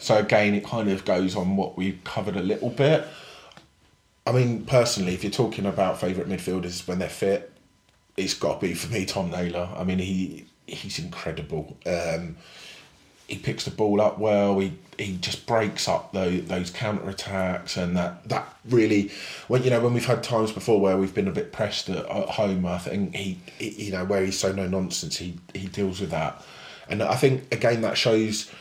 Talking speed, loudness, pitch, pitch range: 200 wpm, -25 LUFS, 95 Hz, 90-110 Hz